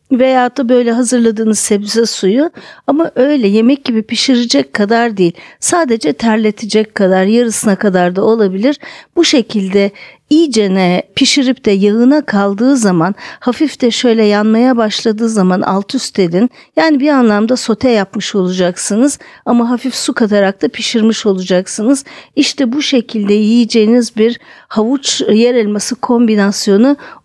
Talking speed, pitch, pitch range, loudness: 130 wpm, 230 Hz, 205-255 Hz, -12 LUFS